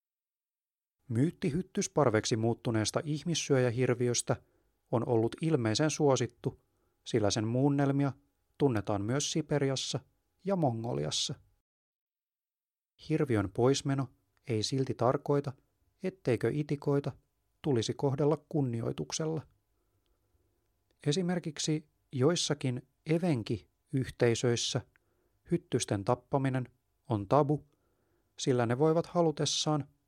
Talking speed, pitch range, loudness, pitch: 75 wpm, 115-150 Hz, -32 LUFS, 130 Hz